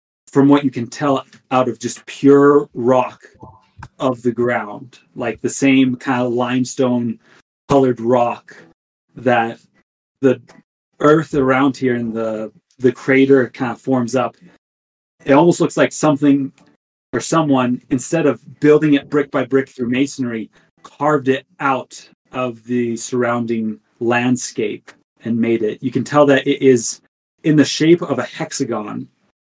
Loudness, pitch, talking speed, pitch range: -17 LUFS, 130 Hz, 145 wpm, 120-140 Hz